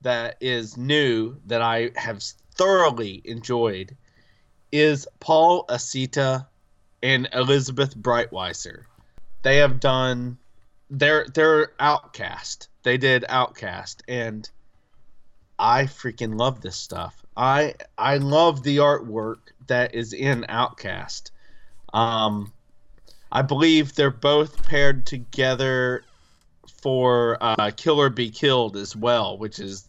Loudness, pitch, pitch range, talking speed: -22 LUFS, 125 Hz, 110-140 Hz, 110 wpm